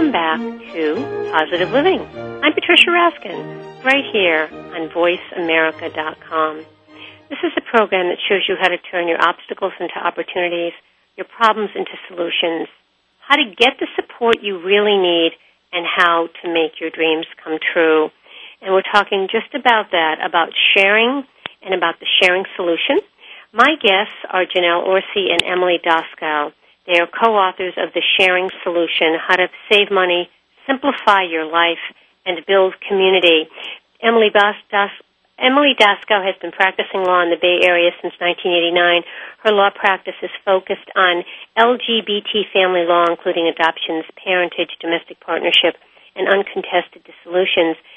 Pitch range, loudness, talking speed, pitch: 170-205 Hz, -16 LUFS, 140 wpm, 180 Hz